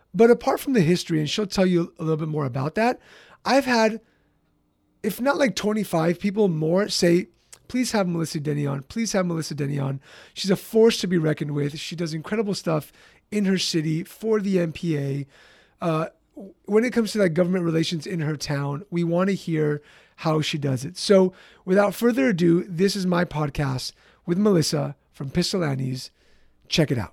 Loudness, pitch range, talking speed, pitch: -23 LUFS, 155-200 Hz, 185 wpm, 175 Hz